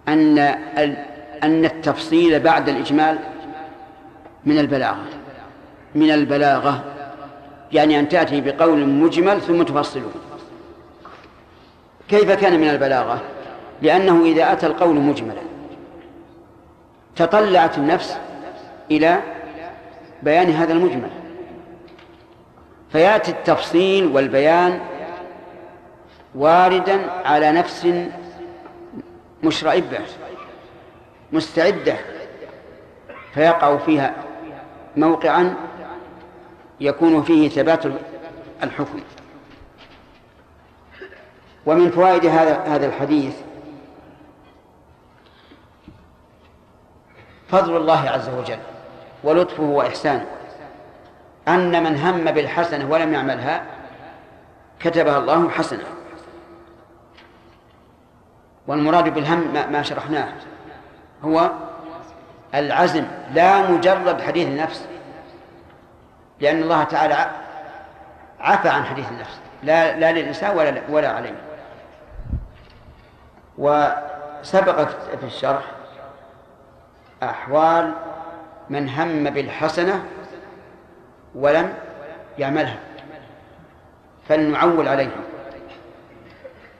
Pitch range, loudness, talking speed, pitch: 145-170 Hz, -18 LUFS, 65 wpm, 155 Hz